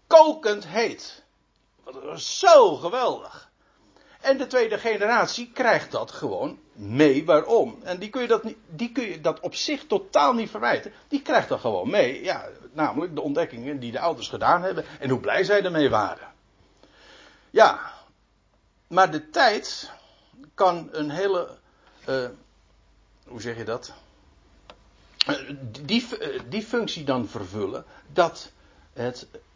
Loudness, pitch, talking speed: -23 LUFS, 190 Hz, 145 wpm